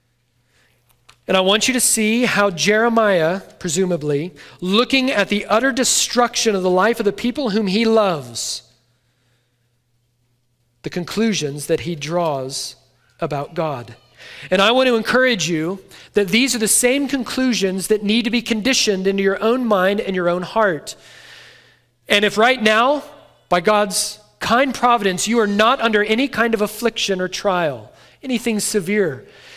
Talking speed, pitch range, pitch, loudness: 150 wpm, 165-230 Hz, 205 Hz, -17 LUFS